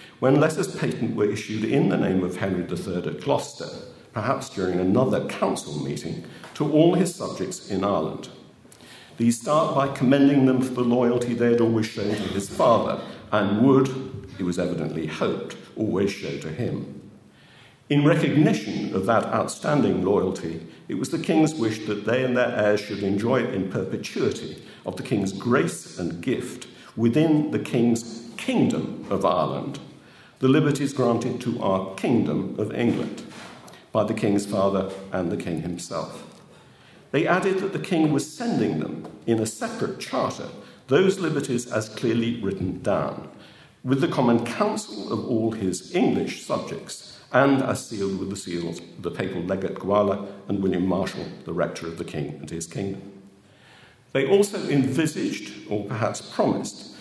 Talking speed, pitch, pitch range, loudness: 160 wpm, 115 Hz, 100-135 Hz, -24 LUFS